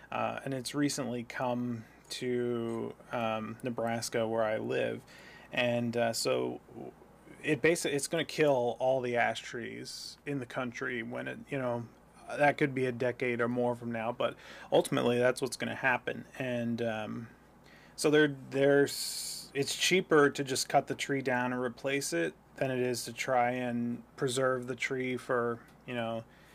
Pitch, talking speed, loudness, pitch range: 125 Hz, 165 wpm, -32 LUFS, 120-135 Hz